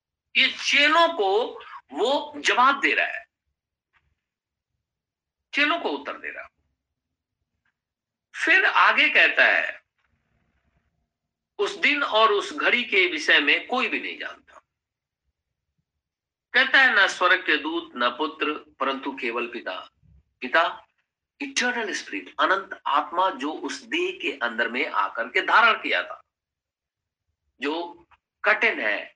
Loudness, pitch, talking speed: -21 LUFS, 285 Hz, 125 wpm